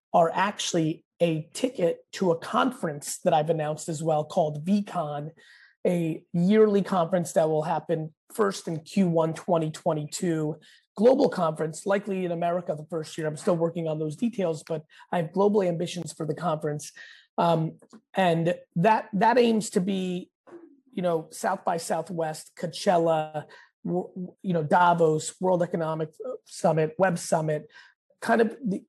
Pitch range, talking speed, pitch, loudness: 160-195 Hz, 145 wpm, 170 Hz, -26 LUFS